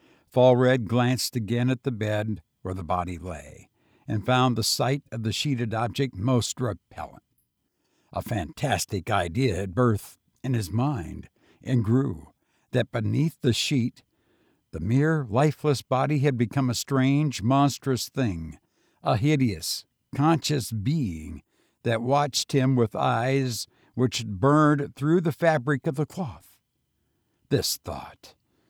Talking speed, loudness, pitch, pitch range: 130 wpm, -25 LUFS, 125 Hz, 110-140 Hz